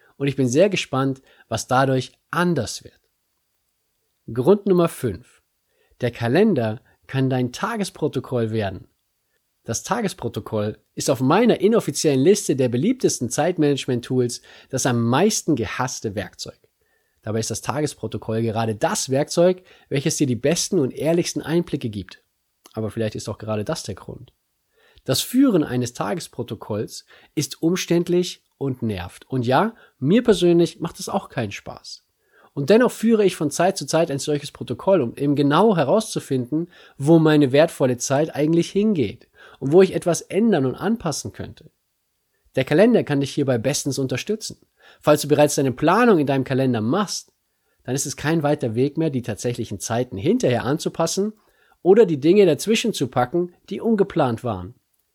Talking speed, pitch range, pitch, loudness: 150 wpm, 125-175 Hz, 145 Hz, -21 LUFS